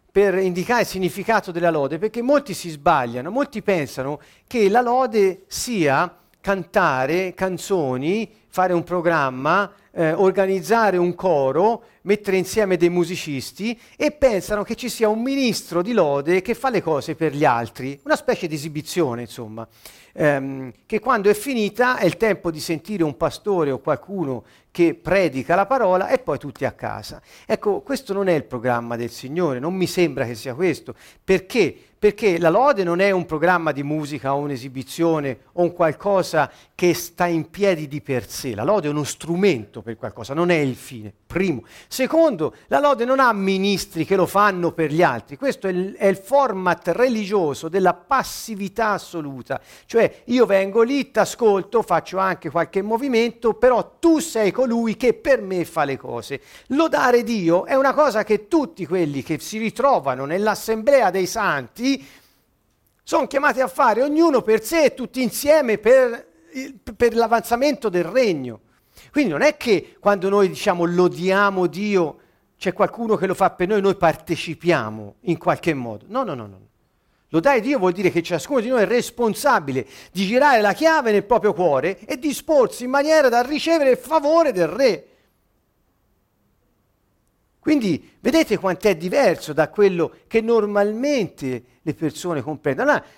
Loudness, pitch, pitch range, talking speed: -20 LUFS, 190 Hz, 160-230 Hz, 165 wpm